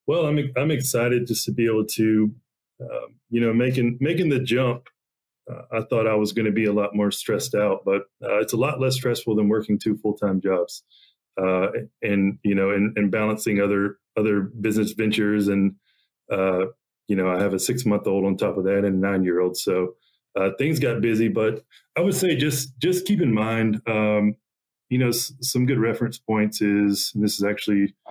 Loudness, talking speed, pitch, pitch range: -23 LUFS, 210 wpm, 110 Hz, 100-120 Hz